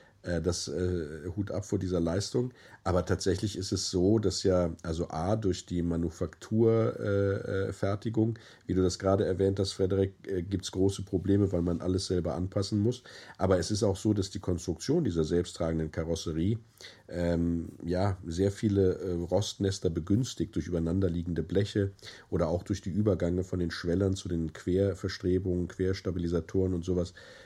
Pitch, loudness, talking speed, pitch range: 95 Hz, -30 LUFS, 160 wpm, 85-100 Hz